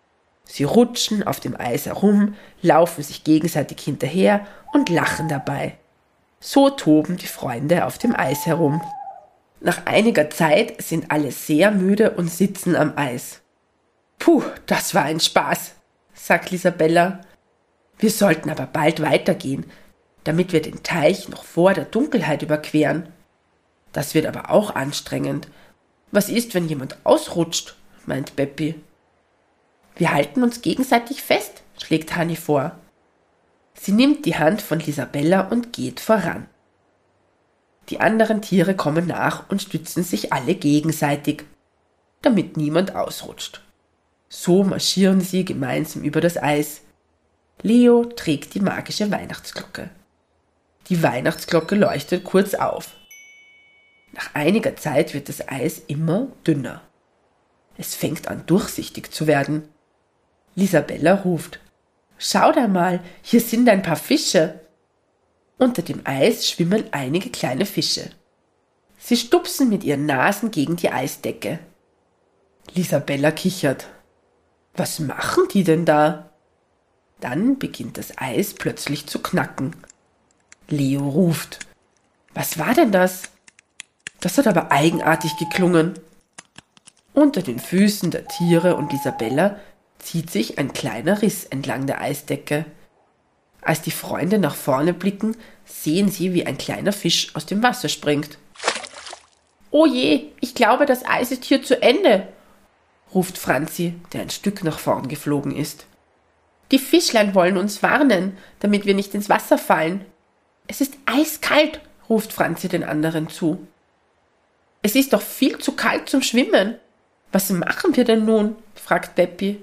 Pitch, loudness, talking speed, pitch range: 175 Hz, -20 LUFS, 130 wpm, 155-215 Hz